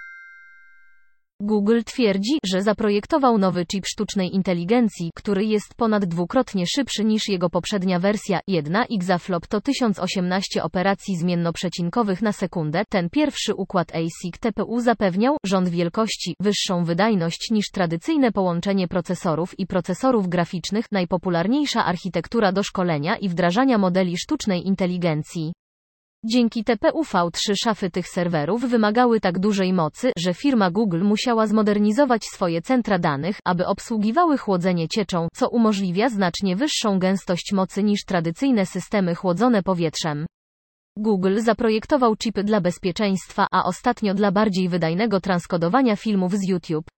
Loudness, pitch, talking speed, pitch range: -22 LUFS, 195 Hz, 125 wpm, 180-220 Hz